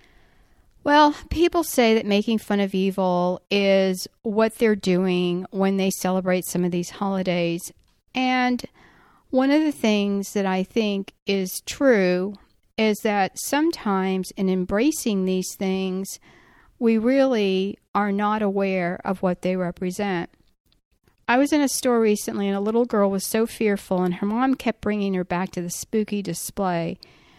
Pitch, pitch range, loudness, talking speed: 200 Hz, 185-225 Hz, -23 LUFS, 150 wpm